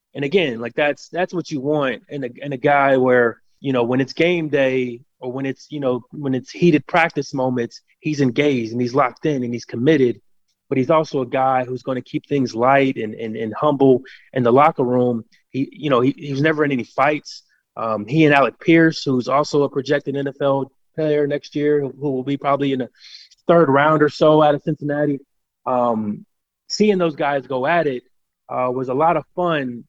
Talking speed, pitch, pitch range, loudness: 215 wpm, 140 Hz, 125-150 Hz, -19 LUFS